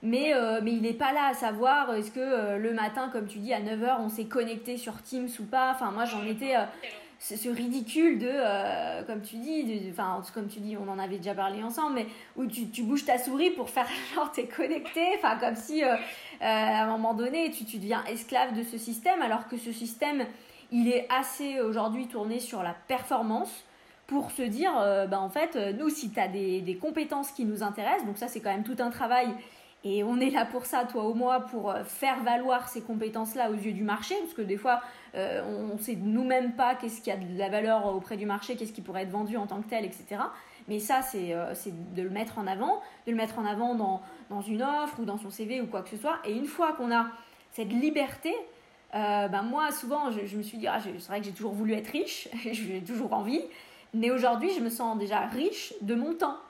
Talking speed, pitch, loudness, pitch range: 245 wpm, 230 Hz, -30 LUFS, 210-255 Hz